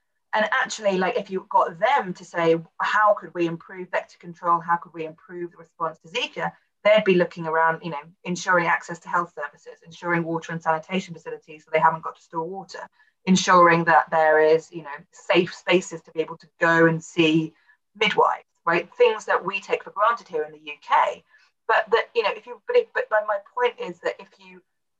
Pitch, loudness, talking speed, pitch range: 170 Hz, -22 LUFS, 210 wpm, 165-195 Hz